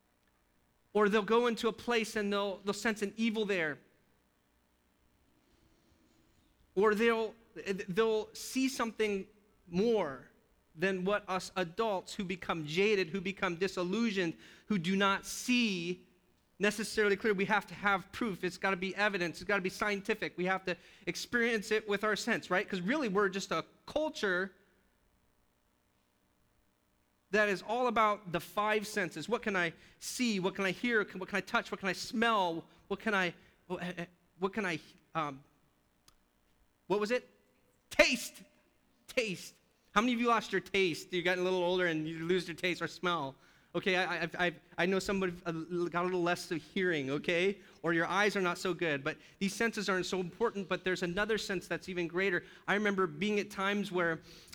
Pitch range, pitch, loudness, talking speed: 170-210 Hz, 190 Hz, -33 LUFS, 175 wpm